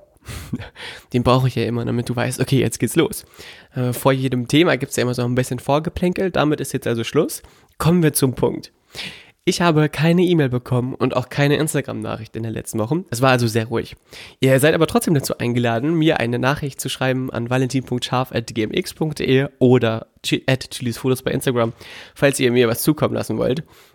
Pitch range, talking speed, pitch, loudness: 120-145 Hz, 190 wpm, 130 Hz, -19 LUFS